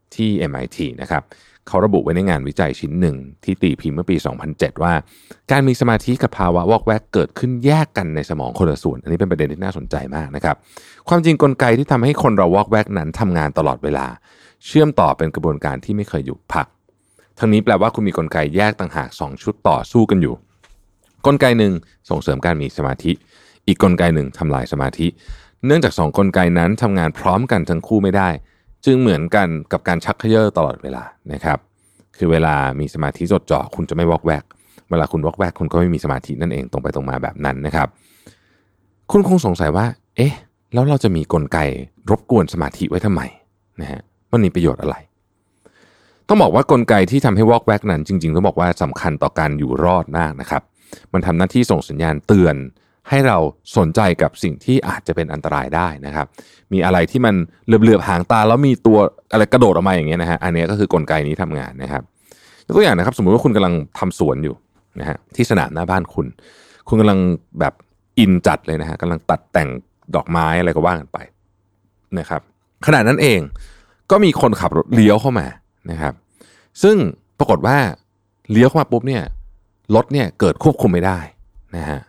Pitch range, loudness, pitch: 80-105 Hz, -17 LUFS, 90 Hz